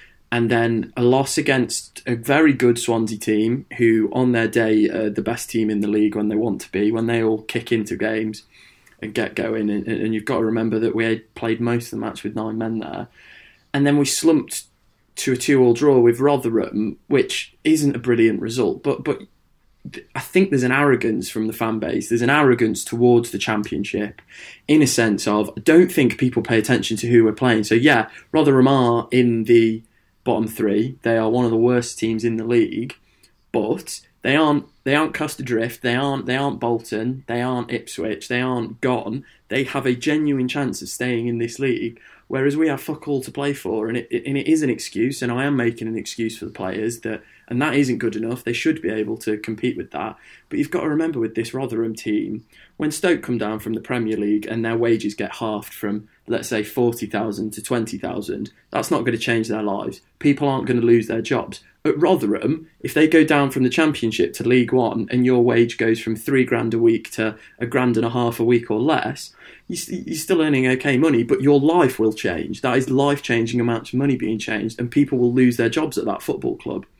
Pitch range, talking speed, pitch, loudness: 110-135 Hz, 220 wpm, 120 Hz, -20 LUFS